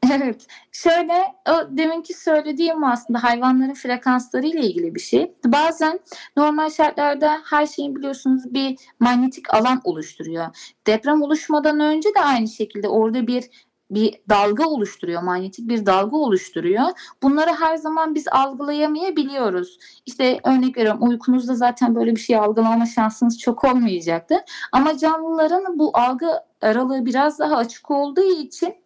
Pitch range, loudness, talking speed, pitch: 235-315 Hz, -19 LUFS, 130 wpm, 270 Hz